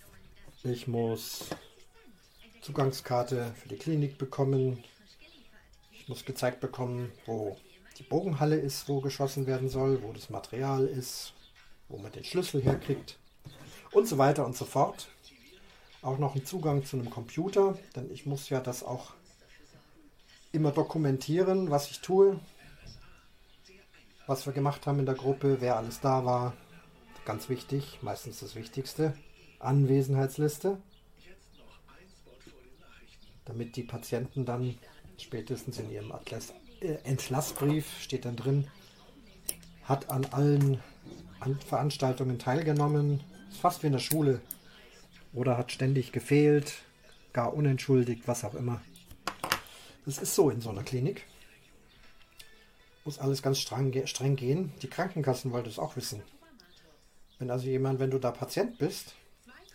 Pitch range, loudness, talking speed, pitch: 125-145 Hz, -31 LUFS, 130 wpm, 135 Hz